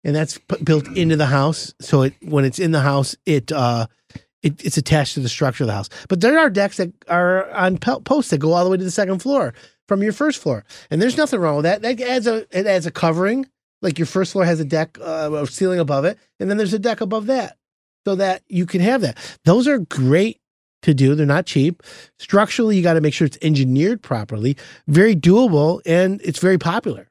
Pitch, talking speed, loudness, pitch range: 175 Hz, 240 wpm, -18 LUFS, 150-200 Hz